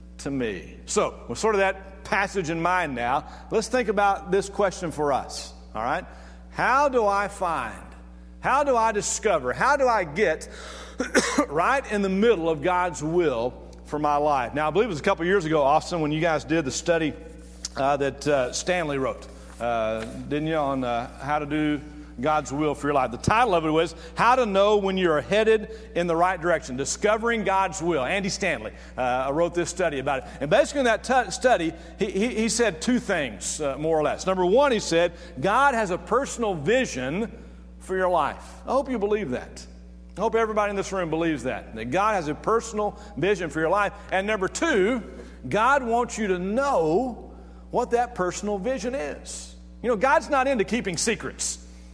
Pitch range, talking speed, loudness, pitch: 140-210 Hz, 200 wpm, -24 LUFS, 175 Hz